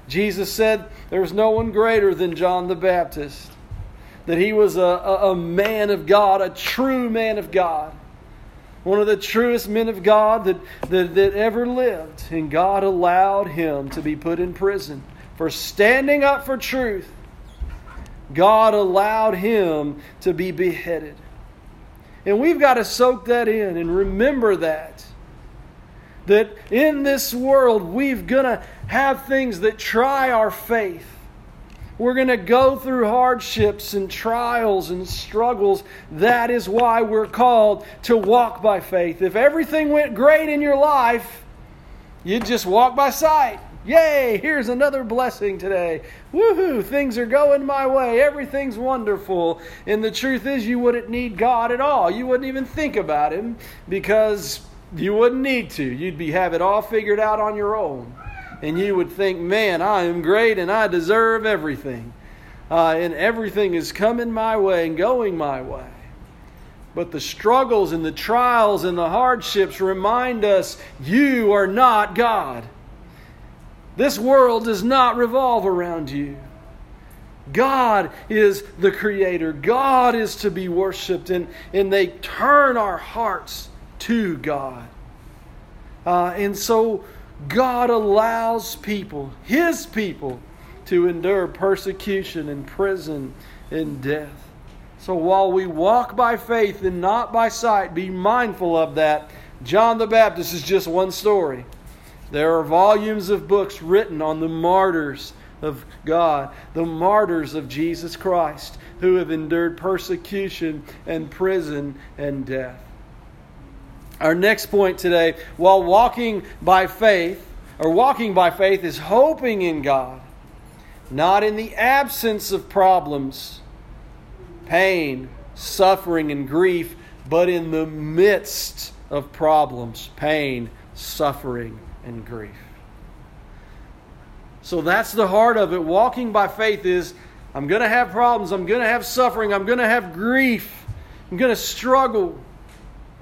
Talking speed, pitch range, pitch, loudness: 145 wpm, 165-230 Hz, 195 Hz, -19 LUFS